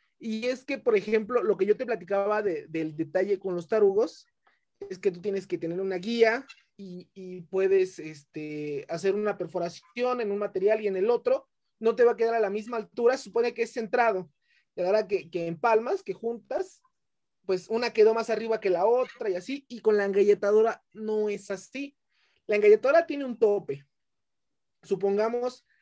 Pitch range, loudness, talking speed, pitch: 190-235 Hz, -27 LUFS, 190 wpm, 215 Hz